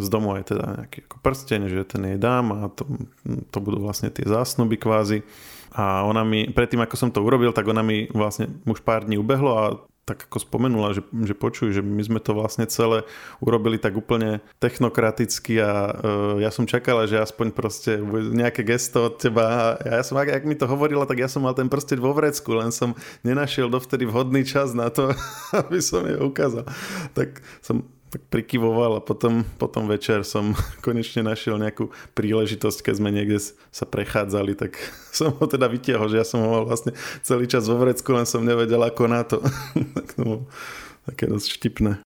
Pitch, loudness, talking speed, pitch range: 115 Hz, -23 LUFS, 195 wpm, 110-125 Hz